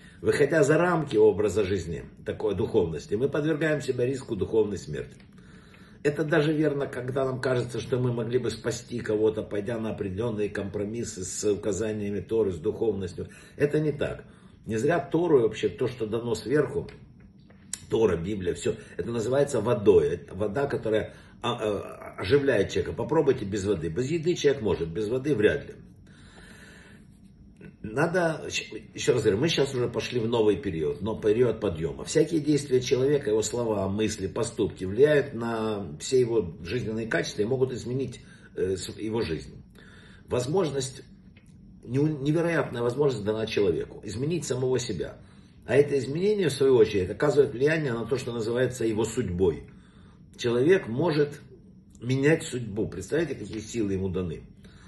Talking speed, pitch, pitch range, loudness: 140 wpm, 125 Hz, 110-150 Hz, -27 LUFS